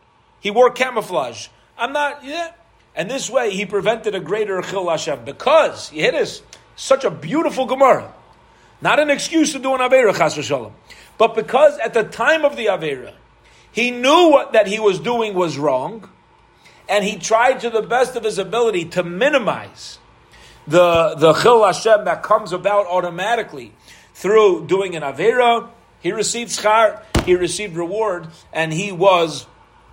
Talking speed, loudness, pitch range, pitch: 160 wpm, -17 LUFS, 190-255 Hz, 220 Hz